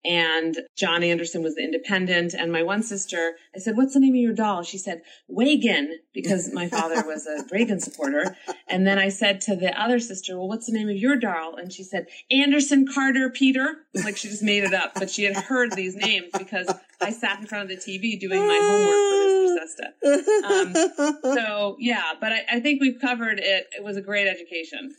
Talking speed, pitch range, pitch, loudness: 215 wpm, 190-265 Hz, 205 Hz, -23 LUFS